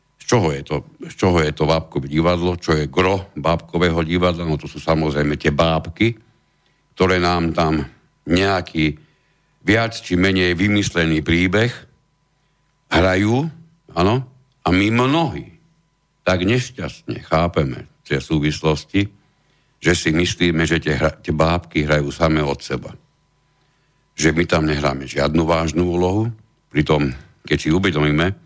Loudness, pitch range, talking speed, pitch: -19 LUFS, 80-100 Hz, 135 wpm, 85 Hz